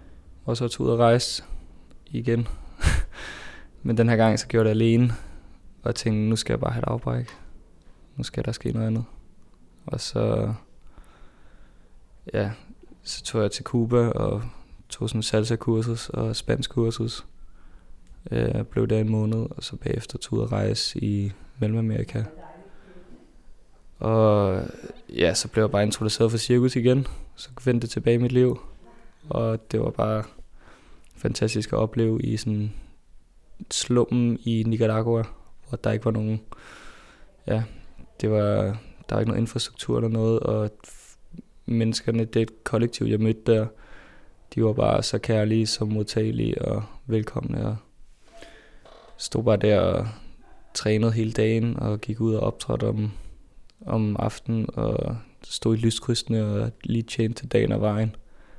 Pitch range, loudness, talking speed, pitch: 110-115 Hz, -25 LUFS, 150 wpm, 110 Hz